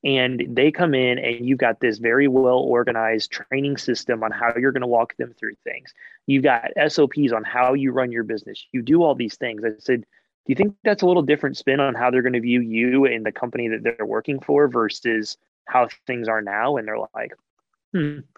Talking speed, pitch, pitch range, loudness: 225 wpm, 125 Hz, 115-140 Hz, -21 LUFS